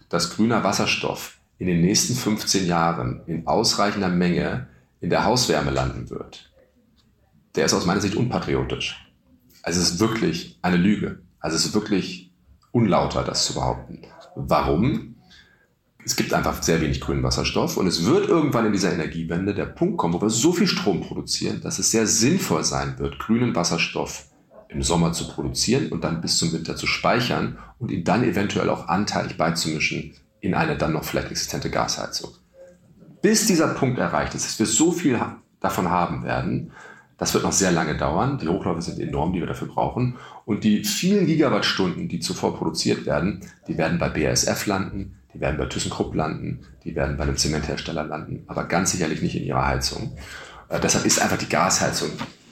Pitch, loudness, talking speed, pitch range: 90 Hz, -22 LUFS, 175 wpm, 75-110 Hz